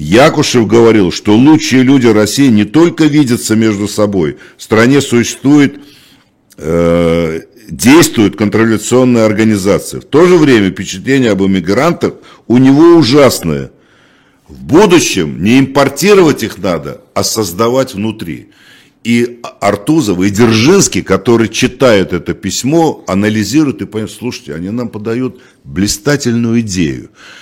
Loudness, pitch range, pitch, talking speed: -10 LUFS, 100-130 Hz, 115 Hz, 120 wpm